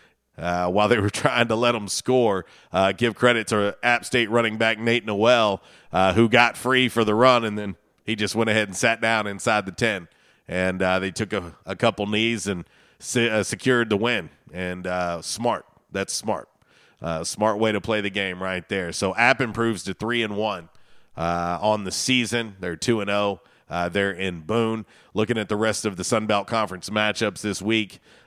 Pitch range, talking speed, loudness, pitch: 95-115 Hz, 210 wpm, -23 LUFS, 110 Hz